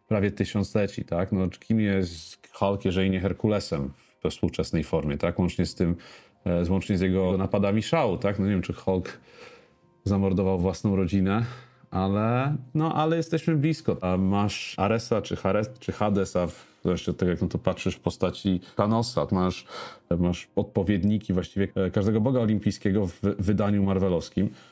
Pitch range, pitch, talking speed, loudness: 90-105 Hz, 95 Hz, 160 wpm, -26 LUFS